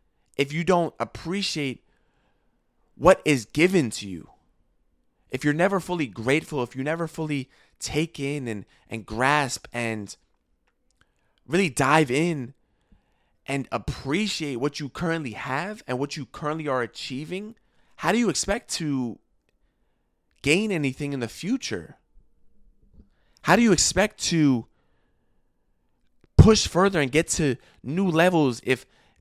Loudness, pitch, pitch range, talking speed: -24 LUFS, 145 Hz, 130-165 Hz, 125 wpm